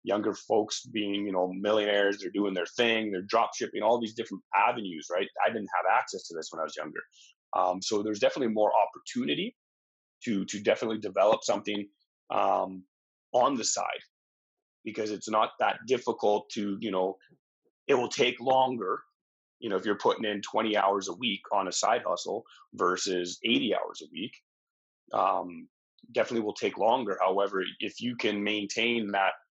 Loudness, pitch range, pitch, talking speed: -29 LUFS, 95-110 Hz, 100 Hz, 170 wpm